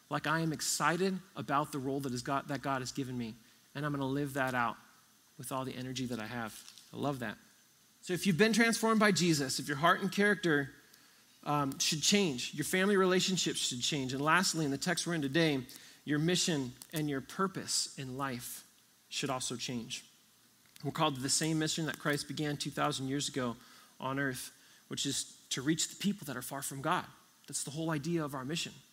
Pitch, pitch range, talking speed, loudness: 145 Hz, 135-165 Hz, 205 wpm, -33 LUFS